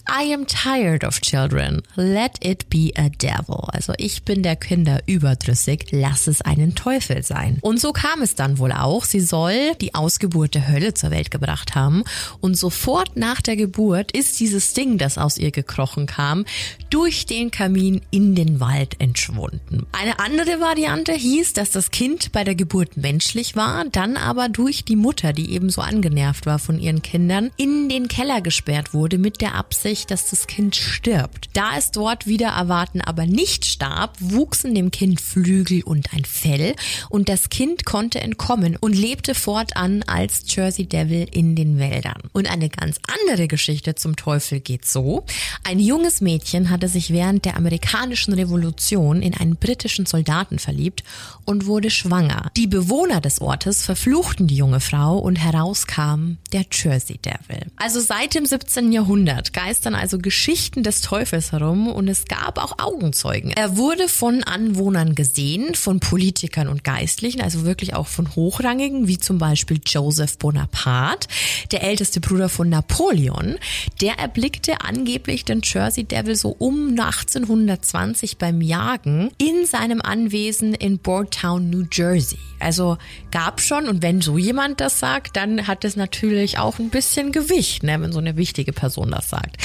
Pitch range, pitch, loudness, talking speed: 155-220 Hz, 185 Hz, -19 LUFS, 165 wpm